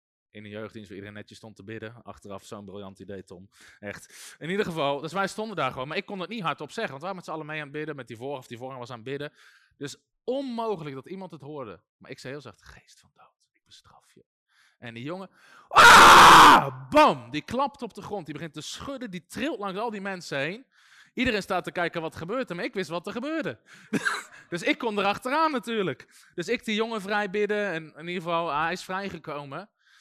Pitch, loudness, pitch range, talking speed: 165 Hz, -22 LUFS, 130-205 Hz, 240 wpm